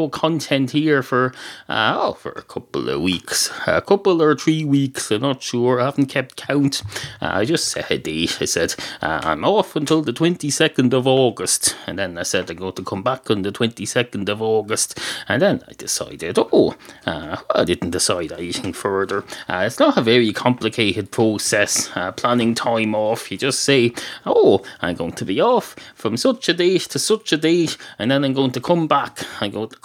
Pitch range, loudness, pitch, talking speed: 115-155 Hz, -19 LUFS, 130 Hz, 205 wpm